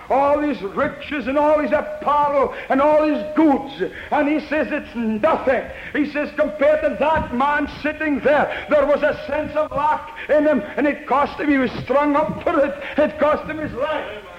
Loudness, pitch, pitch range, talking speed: -19 LUFS, 295 Hz, 280-300 Hz, 195 wpm